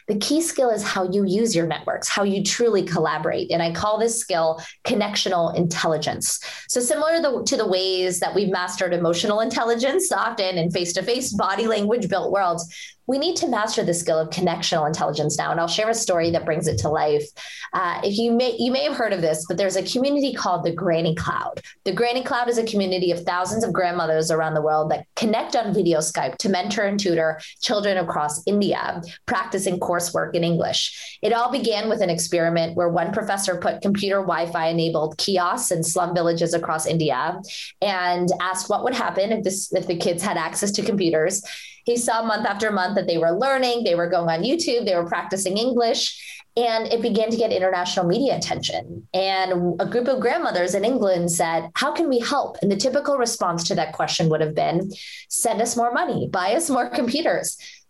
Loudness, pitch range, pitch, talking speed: -22 LUFS, 170-230 Hz, 190 Hz, 205 wpm